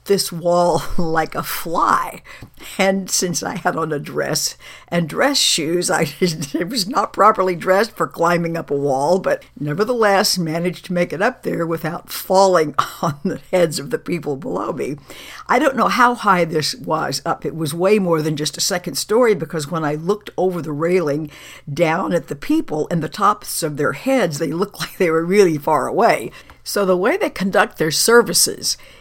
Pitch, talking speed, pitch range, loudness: 175 Hz, 190 wpm, 160-195 Hz, -18 LUFS